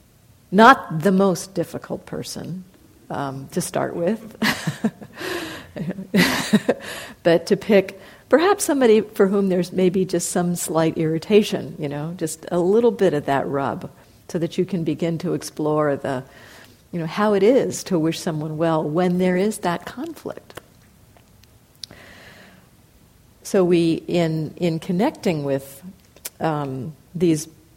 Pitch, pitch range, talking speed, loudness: 175 Hz, 160-195 Hz, 130 wpm, -21 LUFS